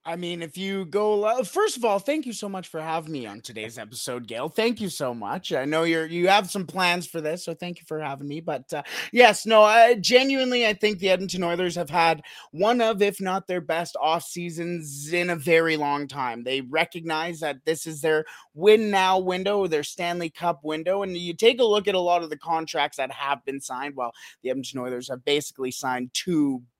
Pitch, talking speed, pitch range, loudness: 170 Hz, 225 wpm, 150-195 Hz, -24 LUFS